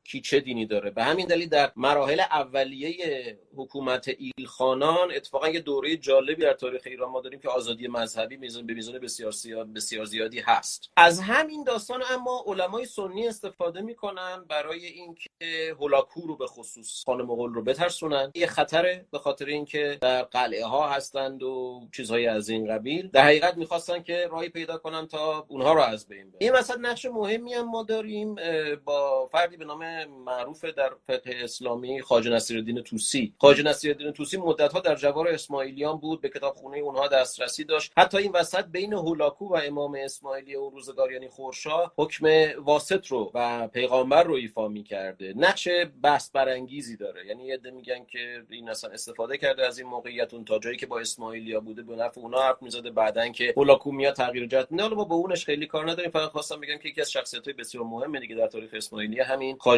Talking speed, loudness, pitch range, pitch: 185 wpm, -26 LUFS, 125-170 Hz, 140 Hz